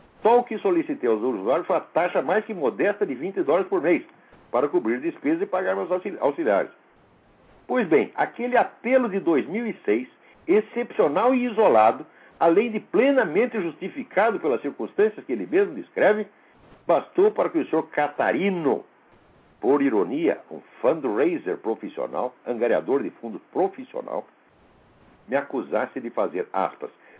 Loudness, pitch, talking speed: -24 LUFS, 255 Hz, 140 wpm